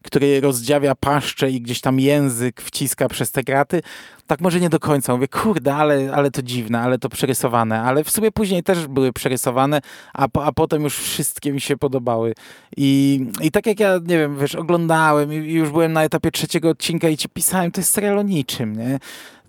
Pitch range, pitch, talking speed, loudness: 135-160 Hz, 145 Hz, 200 wpm, -19 LUFS